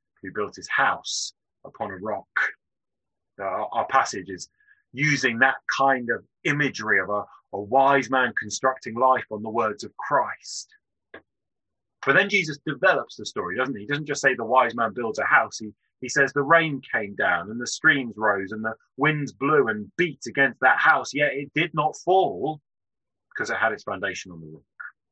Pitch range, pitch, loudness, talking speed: 115-150 Hz, 135 Hz, -23 LUFS, 190 wpm